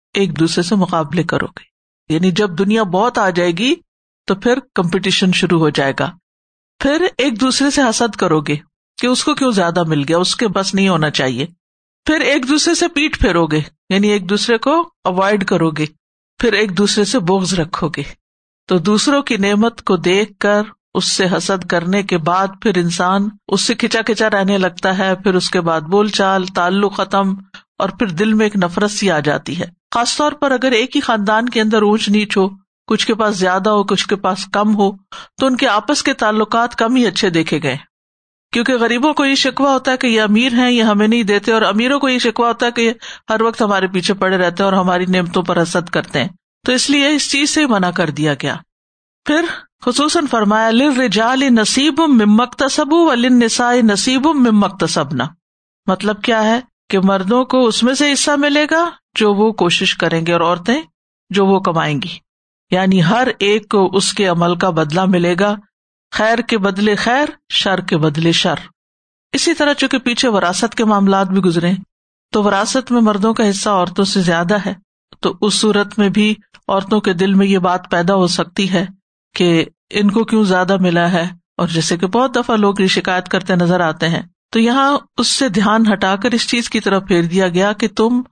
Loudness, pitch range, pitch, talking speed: -15 LUFS, 185-235 Hz, 205 Hz, 205 wpm